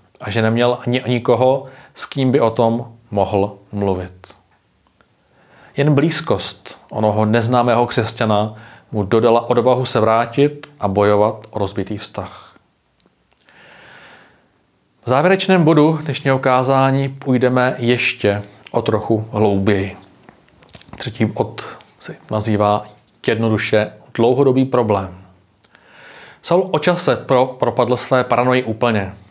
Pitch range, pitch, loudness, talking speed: 105-130 Hz, 115 Hz, -17 LUFS, 105 wpm